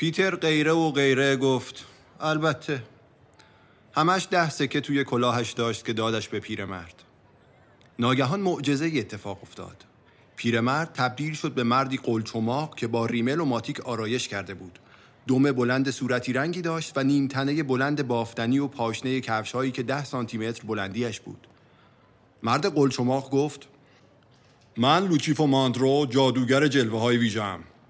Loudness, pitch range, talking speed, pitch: -25 LUFS, 115-145 Hz, 135 wpm, 130 Hz